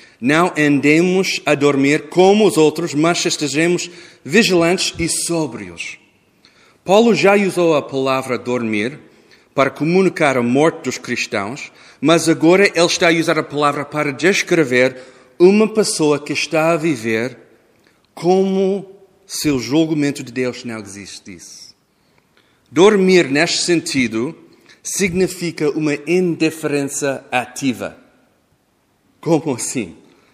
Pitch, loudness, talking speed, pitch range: 160 Hz, -16 LUFS, 115 wpm, 140-175 Hz